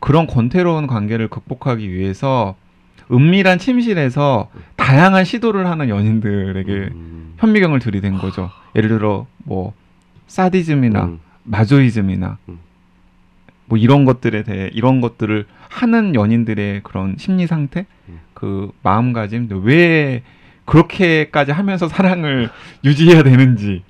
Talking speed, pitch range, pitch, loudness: 275 characters per minute, 100-155 Hz, 120 Hz, -15 LUFS